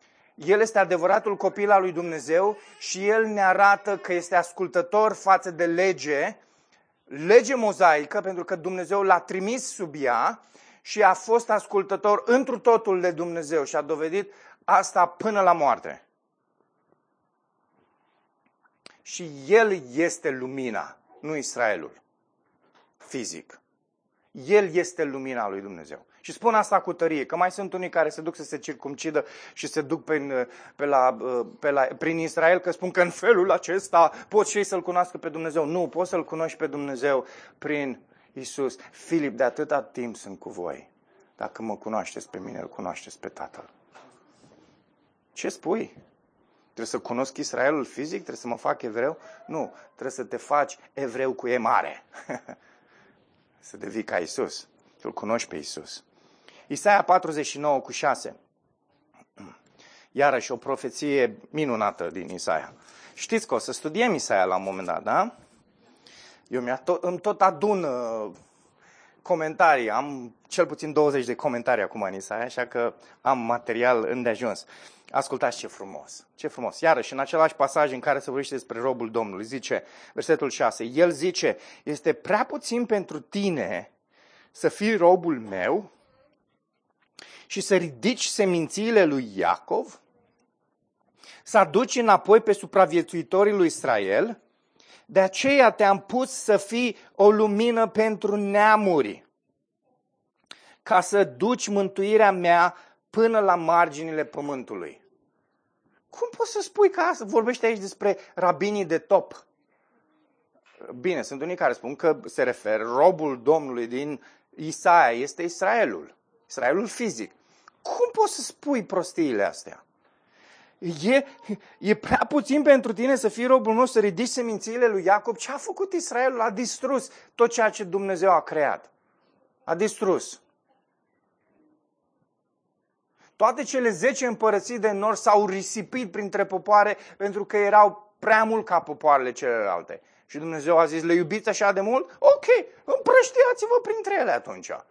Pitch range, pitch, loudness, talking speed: 155-220 Hz, 190 Hz, -24 LUFS, 140 wpm